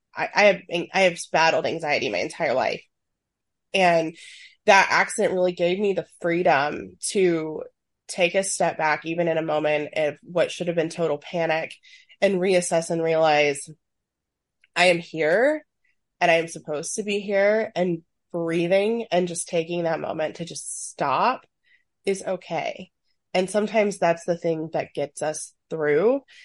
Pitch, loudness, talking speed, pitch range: 175 Hz, -23 LUFS, 155 wpm, 160-195 Hz